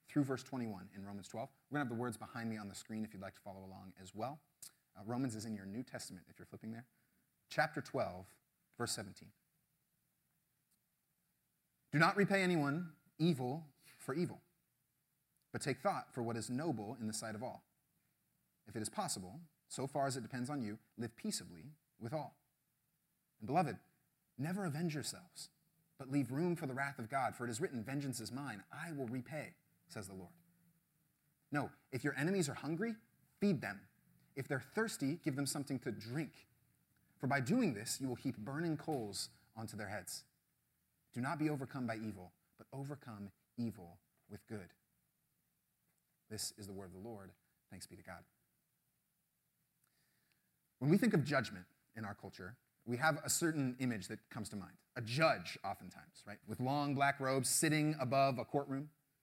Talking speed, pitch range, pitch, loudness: 180 wpm, 110-150 Hz, 135 Hz, -40 LUFS